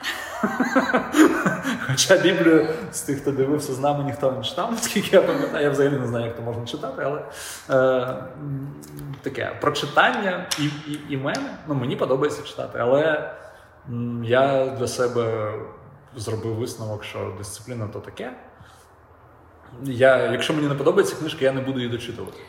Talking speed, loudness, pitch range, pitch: 145 wpm, -22 LUFS, 115-150 Hz, 130 Hz